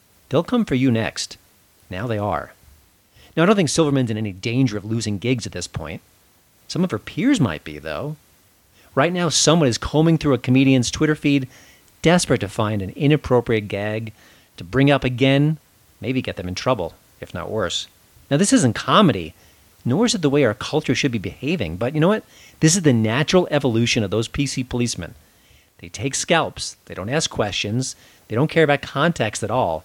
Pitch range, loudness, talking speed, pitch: 105-145 Hz, -20 LUFS, 195 wpm, 125 Hz